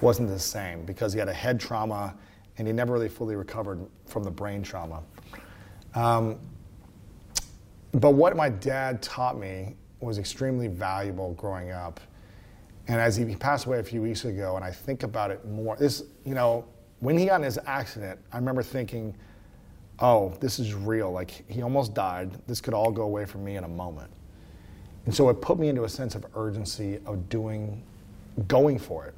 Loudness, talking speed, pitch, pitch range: -28 LUFS, 185 wpm, 105 Hz, 95-120 Hz